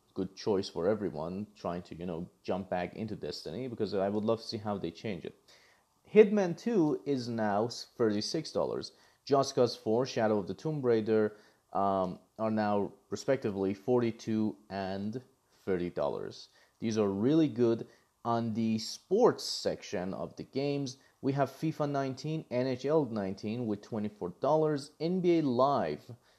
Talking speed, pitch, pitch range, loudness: 140 wpm, 115 Hz, 105-135 Hz, -32 LUFS